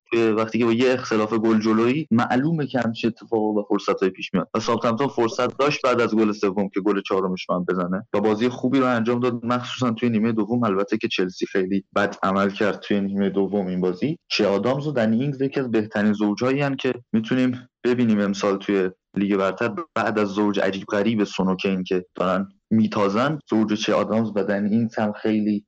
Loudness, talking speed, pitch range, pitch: -22 LUFS, 200 wpm, 100-125 Hz, 110 Hz